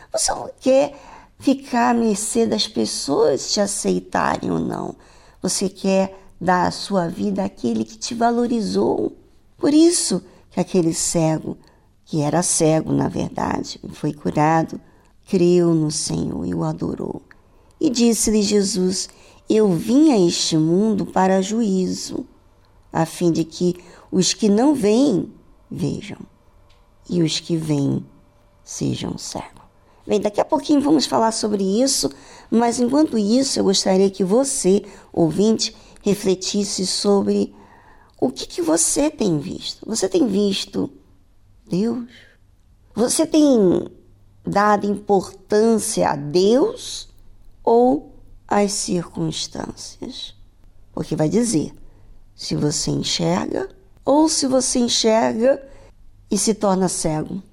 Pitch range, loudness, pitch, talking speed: 160-230 Hz, -19 LUFS, 195 Hz, 120 wpm